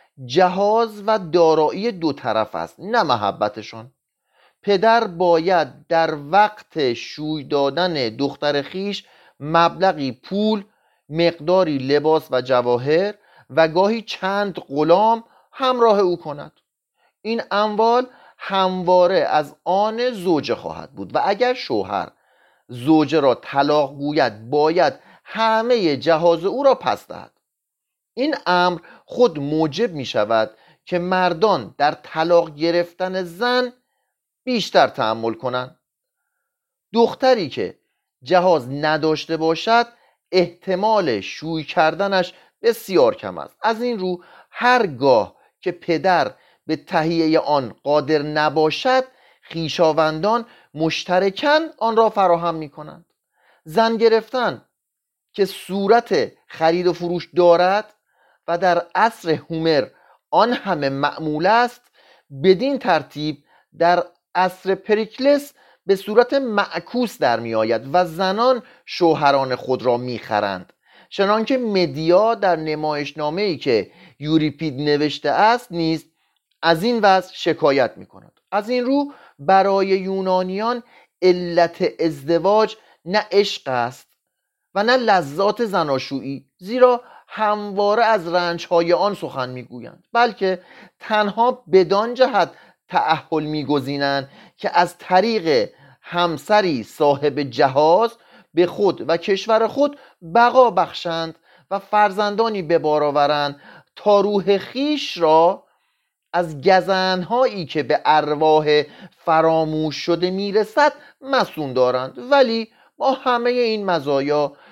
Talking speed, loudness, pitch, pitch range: 110 wpm, -19 LUFS, 180 Hz, 155-220 Hz